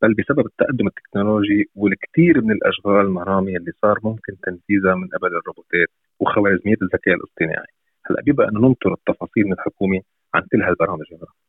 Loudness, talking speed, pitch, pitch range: -19 LUFS, 145 wpm, 100 Hz, 95-105 Hz